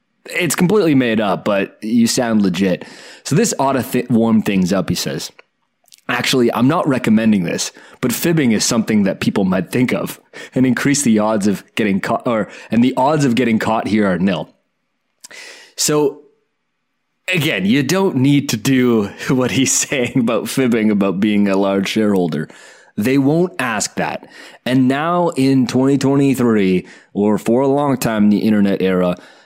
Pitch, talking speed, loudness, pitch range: 125 Hz, 175 wpm, -16 LUFS, 110-145 Hz